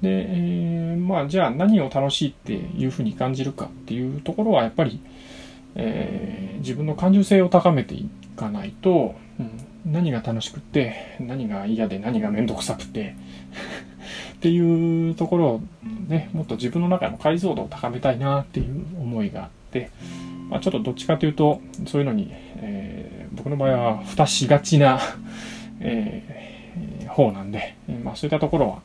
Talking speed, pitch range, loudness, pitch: 340 characters per minute, 115-190 Hz, -23 LUFS, 155 Hz